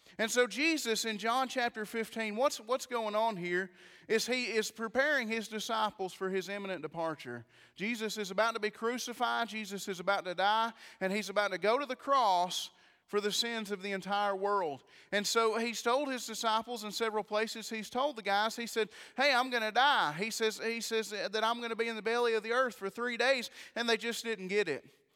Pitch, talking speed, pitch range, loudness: 220 Hz, 220 wpm, 205-235 Hz, -33 LUFS